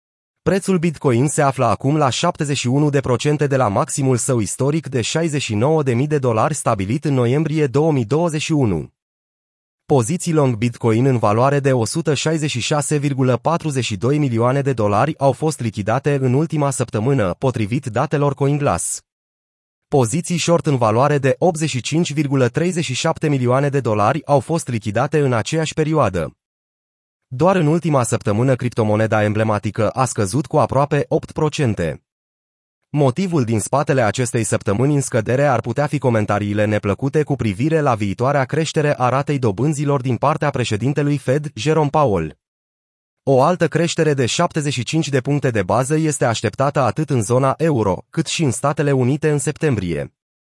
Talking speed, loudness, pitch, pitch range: 135 wpm, -18 LUFS, 135 Hz, 115-150 Hz